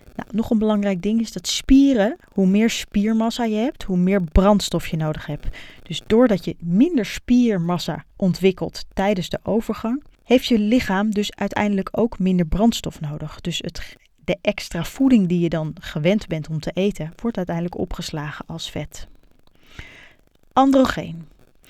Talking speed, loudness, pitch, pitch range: 155 wpm, -21 LUFS, 195 Hz, 170-225 Hz